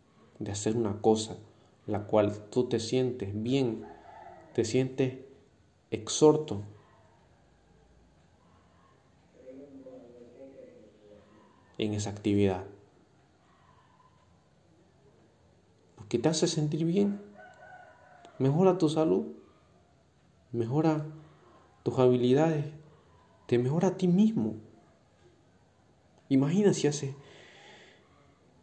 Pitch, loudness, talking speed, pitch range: 120 Hz, -29 LUFS, 75 wpm, 105-150 Hz